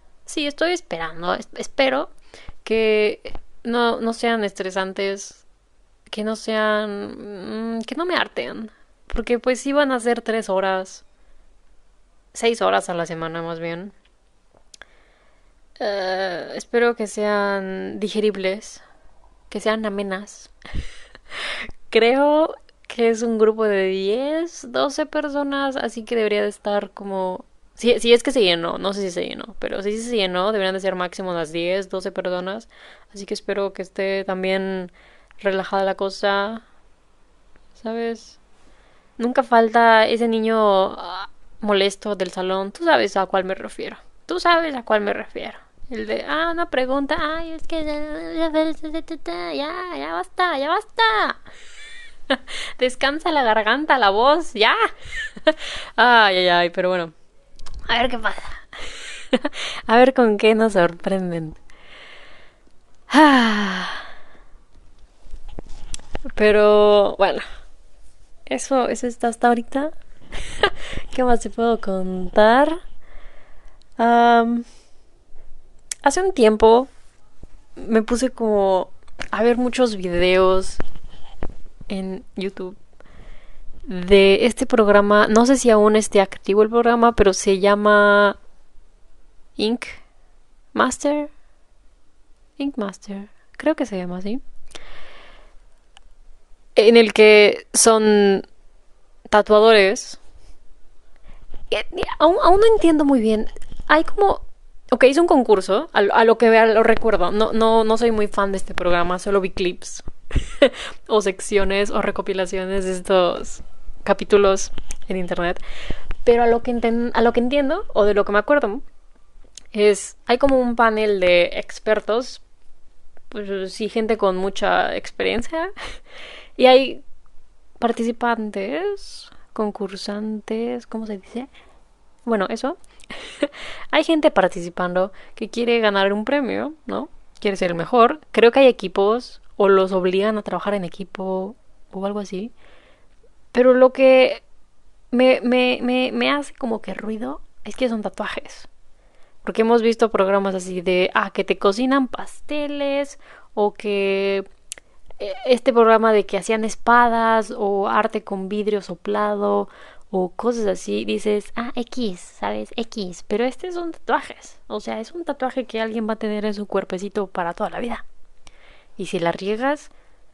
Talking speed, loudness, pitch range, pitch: 130 wpm, -19 LUFS, 195-250 Hz, 220 Hz